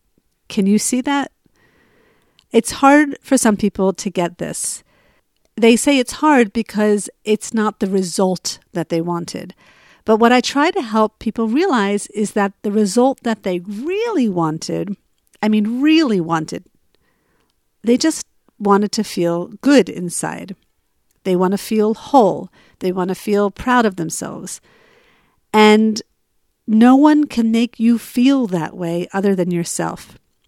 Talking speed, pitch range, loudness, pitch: 150 wpm, 190-245 Hz, -17 LUFS, 215 Hz